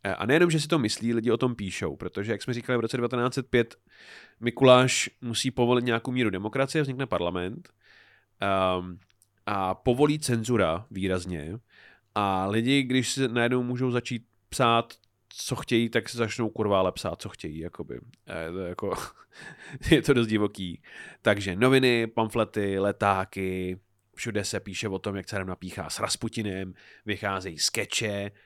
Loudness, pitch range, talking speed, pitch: -27 LUFS, 95-120 Hz, 150 wpm, 110 Hz